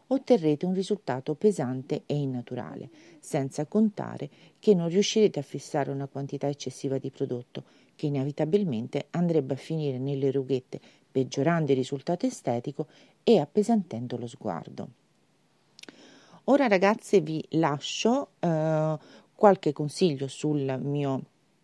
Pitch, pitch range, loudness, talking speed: 150 Hz, 135-190 Hz, -28 LUFS, 115 wpm